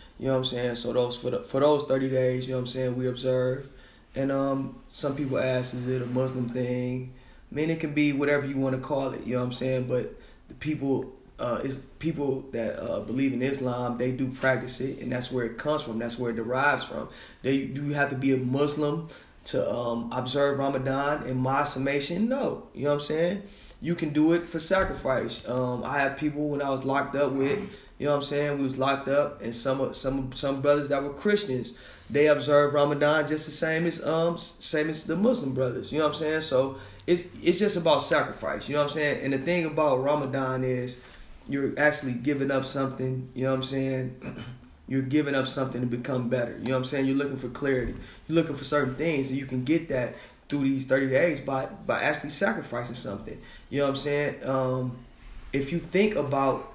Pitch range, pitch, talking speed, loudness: 130-145 Hz, 135 Hz, 230 wpm, -27 LUFS